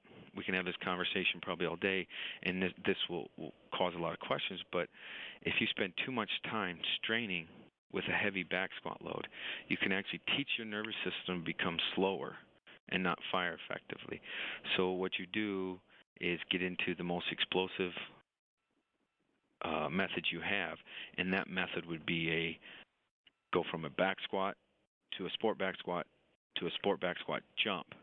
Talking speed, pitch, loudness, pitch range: 175 wpm, 90 Hz, -37 LUFS, 85-95 Hz